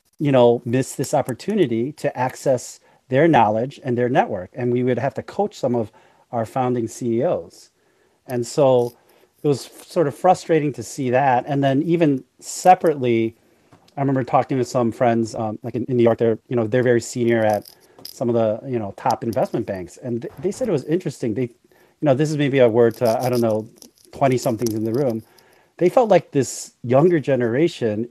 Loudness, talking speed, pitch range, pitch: -20 LUFS, 200 wpm, 115-145 Hz, 125 Hz